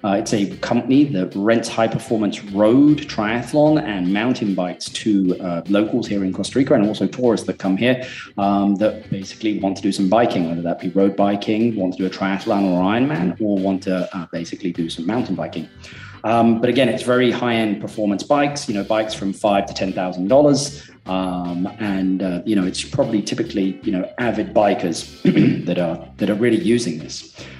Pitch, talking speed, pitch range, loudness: 100 Hz, 195 wpm, 95-115 Hz, -19 LUFS